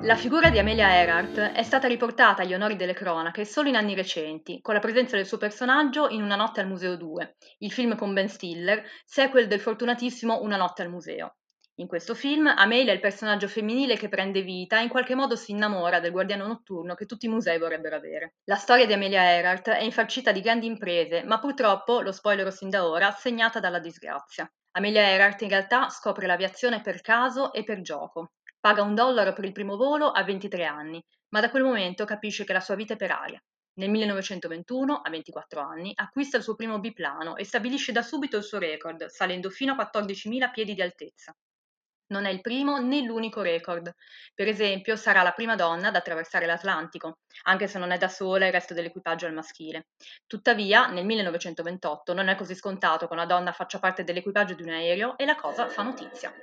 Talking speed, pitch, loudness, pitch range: 205 wpm, 200 Hz, -25 LUFS, 180-230 Hz